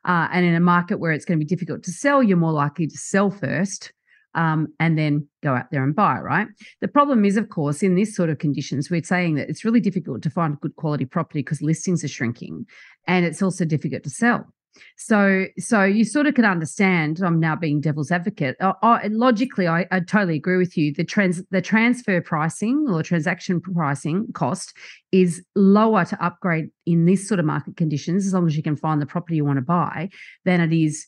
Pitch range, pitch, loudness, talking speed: 155-195 Hz, 175 Hz, -21 LUFS, 220 wpm